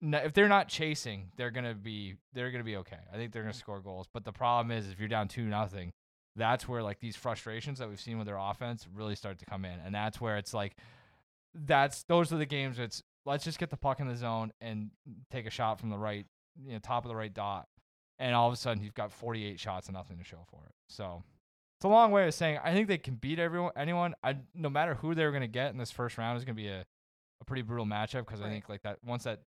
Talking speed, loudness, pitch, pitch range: 275 wpm, -34 LUFS, 115 Hz, 105-135 Hz